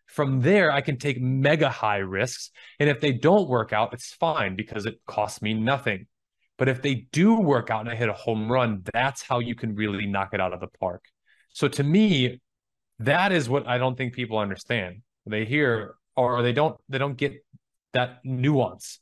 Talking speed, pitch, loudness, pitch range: 205 wpm, 125 Hz, -25 LUFS, 110-140 Hz